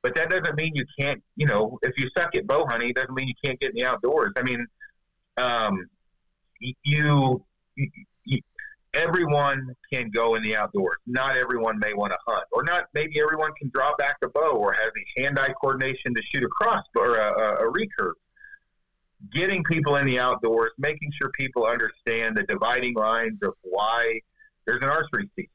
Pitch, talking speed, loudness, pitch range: 135 Hz, 190 wpm, -25 LUFS, 115-155 Hz